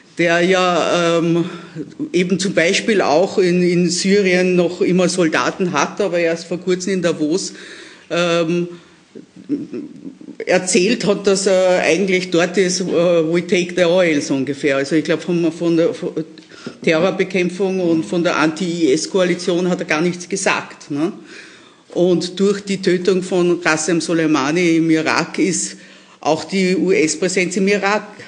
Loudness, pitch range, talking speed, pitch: -17 LUFS, 170-190 Hz, 145 wpm, 175 Hz